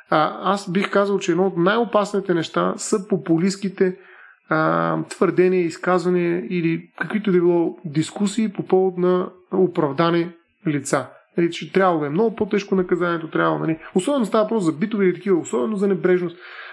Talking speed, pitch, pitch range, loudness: 155 wpm, 180 Hz, 170-195 Hz, -21 LUFS